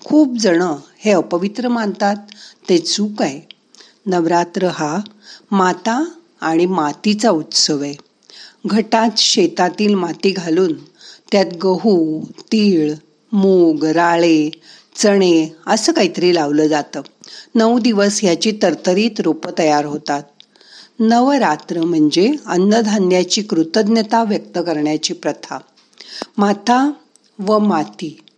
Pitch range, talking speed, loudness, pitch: 165-225 Hz, 95 wpm, -16 LUFS, 195 Hz